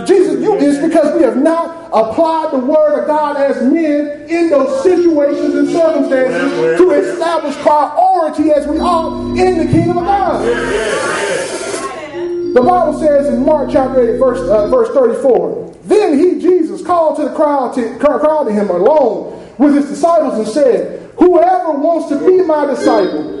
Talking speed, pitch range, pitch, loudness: 165 wpm, 285-345 Hz, 310 Hz, -12 LUFS